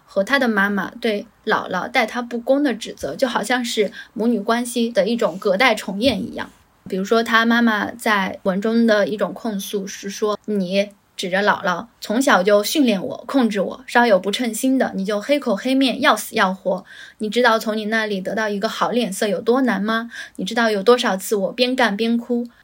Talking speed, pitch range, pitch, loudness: 285 characters per minute, 205-245 Hz, 225 Hz, -19 LUFS